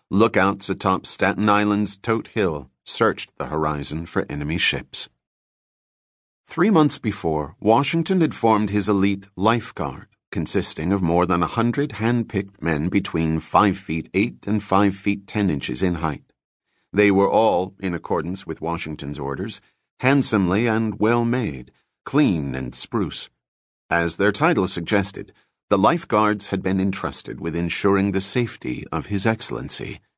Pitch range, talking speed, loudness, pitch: 80-105 Hz, 140 wpm, -22 LUFS, 95 Hz